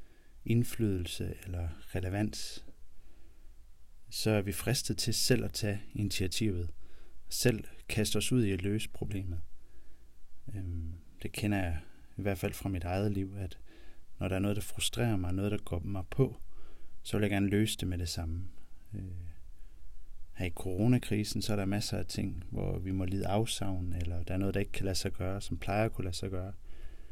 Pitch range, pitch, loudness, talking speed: 85-105 Hz, 95 Hz, -34 LUFS, 185 wpm